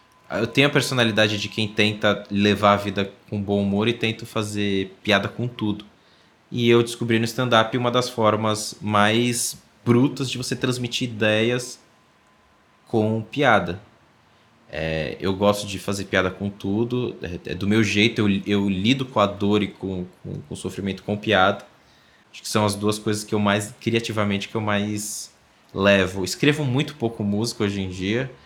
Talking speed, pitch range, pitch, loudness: 175 wpm, 100-120 Hz, 105 Hz, -22 LUFS